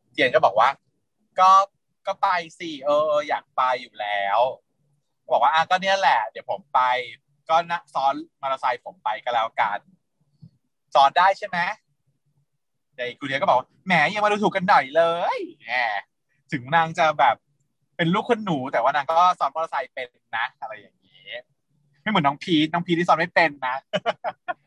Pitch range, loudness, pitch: 140-180 Hz, -22 LUFS, 155 Hz